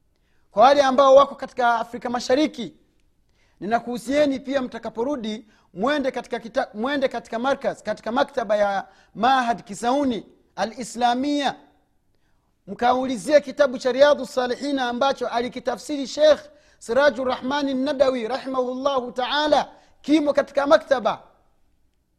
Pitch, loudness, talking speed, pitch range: 255 Hz, -22 LUFS, 105 wpm, 235-280 Hz